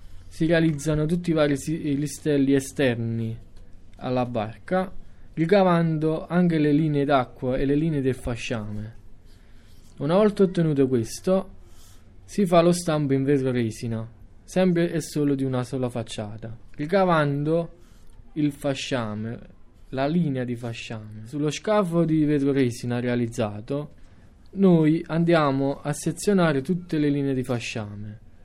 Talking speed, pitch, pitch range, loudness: 125 wpm, 140 Hz, 115-160 Hz, -24 LUFS